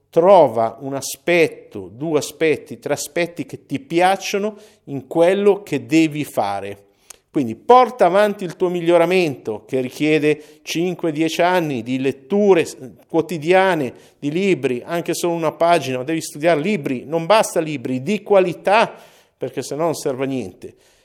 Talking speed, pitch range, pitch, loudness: 140 wpm, 135-180 Hz, 160 Hz, -18 LUFS